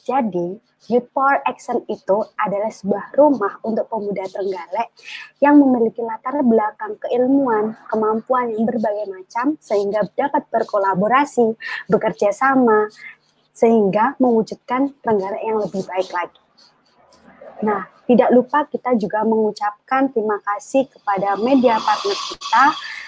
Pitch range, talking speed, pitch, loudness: 210-265 Hz, 115 wpm, 225 Hz, -19 LUFS